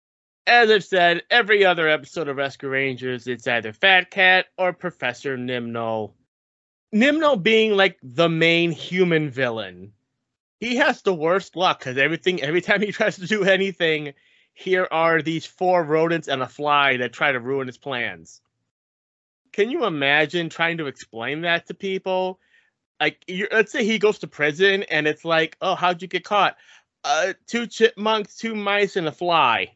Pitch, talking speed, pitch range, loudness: 170 Hz, 170 wpm, 140-195 Hz, -20 LUFS